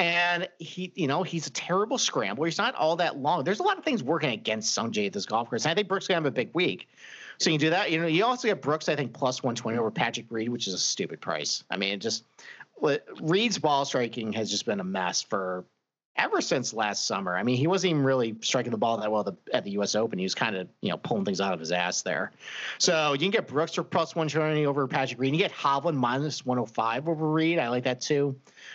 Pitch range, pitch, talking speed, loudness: 115-170 Hz, 140 Hz, 275 wpm, -27 LUFS